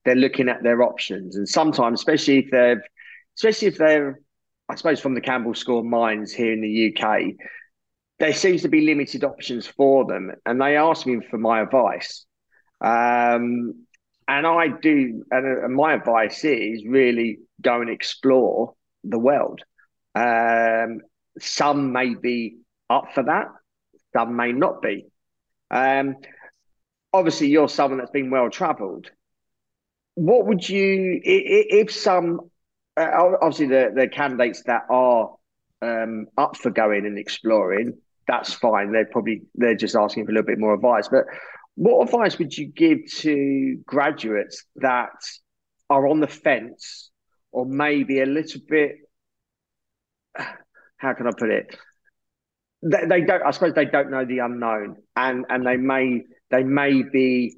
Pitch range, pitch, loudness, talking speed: 115-155 Hz, 130 Hz, -21 LUFS, 150 wpm